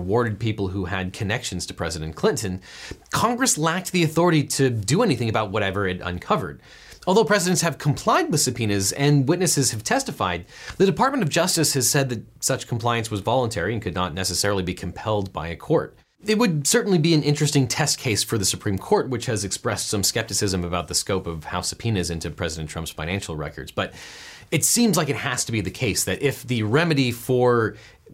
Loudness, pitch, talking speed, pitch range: -22 LUFS, 115 Hz, 195 wpm, 95-145 Hz